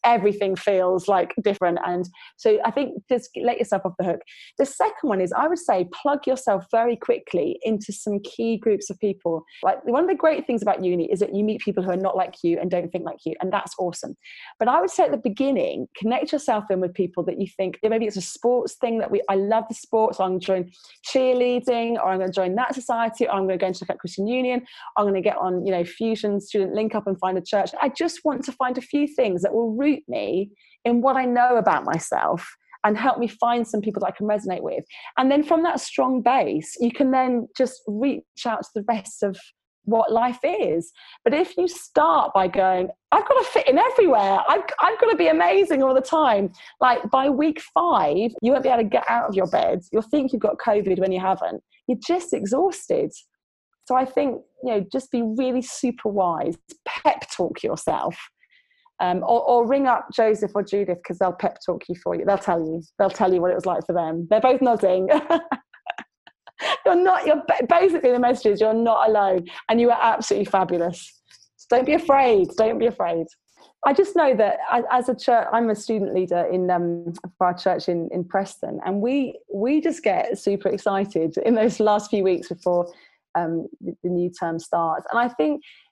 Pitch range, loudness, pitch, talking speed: 190-260 Hz, -22 LUFS, 220 Hz, 225 wpm